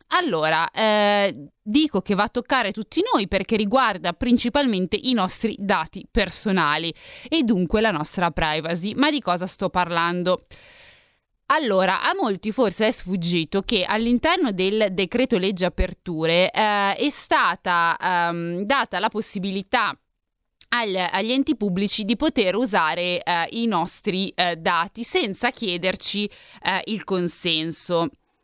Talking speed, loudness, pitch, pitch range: 130 wpm, -22 LUFS, 200 Hz, 180-235 Hz